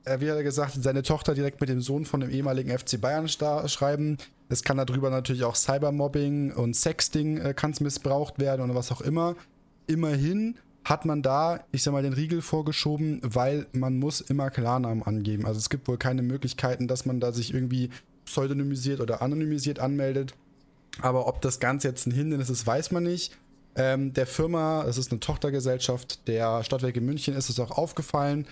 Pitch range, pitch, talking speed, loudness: 125-150 Hz, 135 Hz, 185 wpm, -27 LUFS